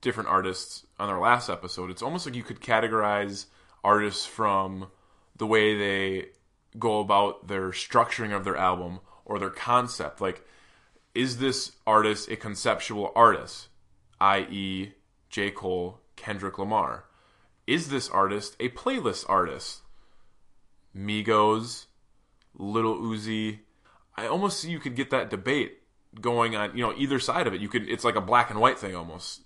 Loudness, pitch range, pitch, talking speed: -27 LUFS, 95-115 Hz, 105 Hz, 150 wpm